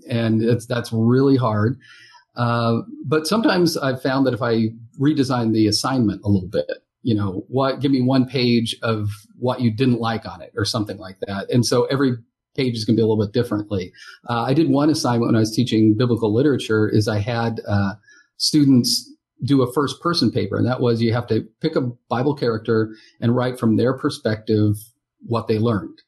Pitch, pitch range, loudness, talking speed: 120 Hz, 110-135 Hz, -20 LUFS, 200 wpm